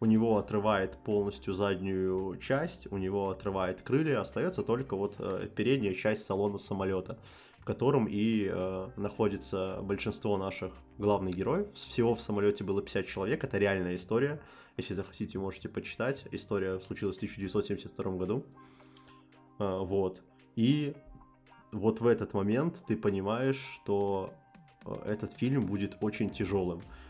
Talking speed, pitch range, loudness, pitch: 125 wpm, 95-110 Hz, -33 LUFS, 100 Hz